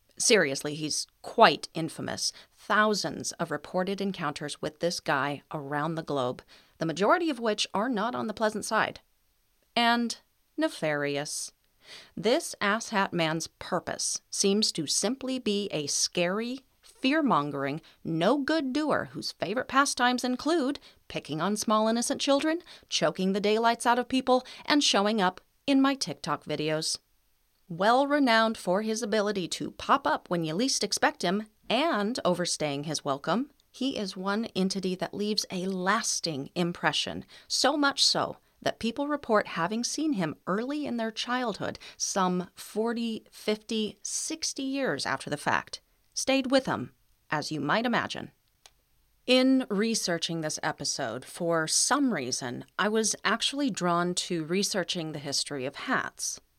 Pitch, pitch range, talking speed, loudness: 205 Hz, 160-250 Hz, 140 wpm, -28 LUFS